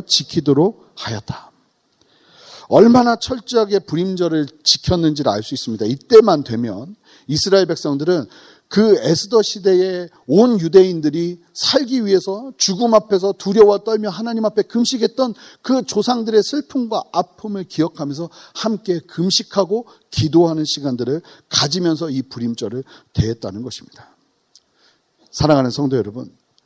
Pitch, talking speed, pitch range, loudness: 180 Hz, 305 characters per minute, 155-215 Hz, -17 LUFS